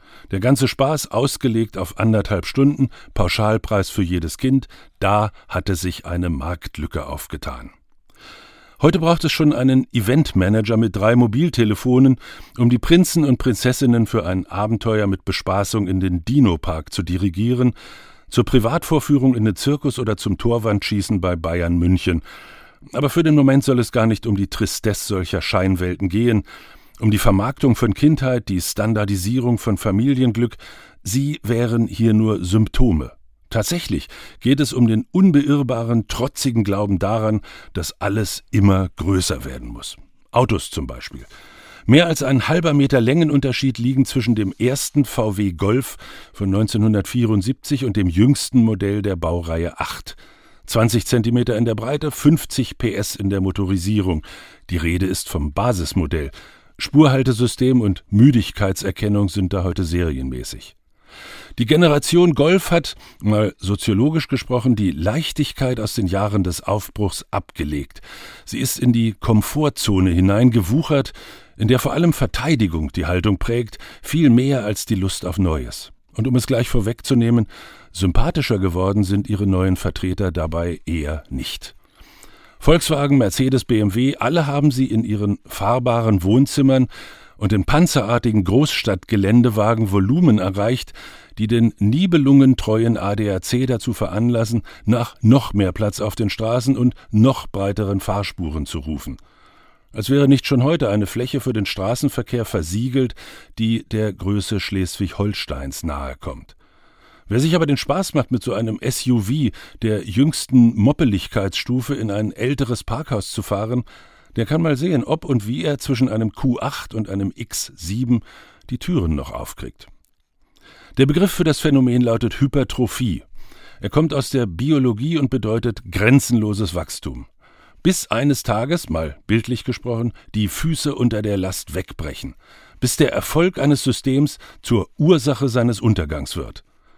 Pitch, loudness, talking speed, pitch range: 115 Hz, -19 LUFS, 140 wpm, 100-130 Hz